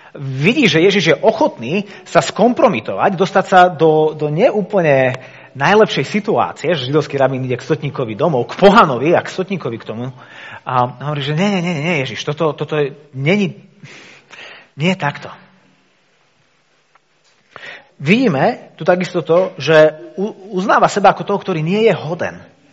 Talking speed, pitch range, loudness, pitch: 150 wpm, 145-195 Hz, -15 LUFS, 170 Hz